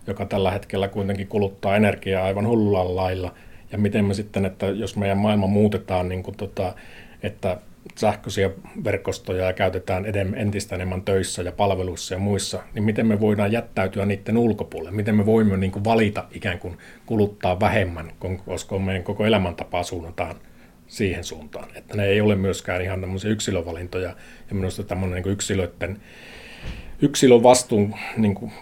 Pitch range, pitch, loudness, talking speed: 95-105 Hz, 100 Hz, -23 LUFS, 160 wpm